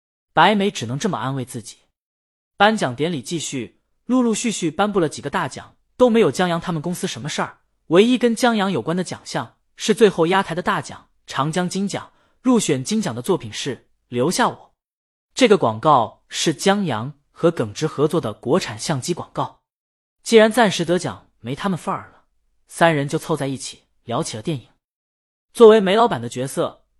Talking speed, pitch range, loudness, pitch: 275 characters per minute, 130-200 Hz, -20 LUFS, 165 Hz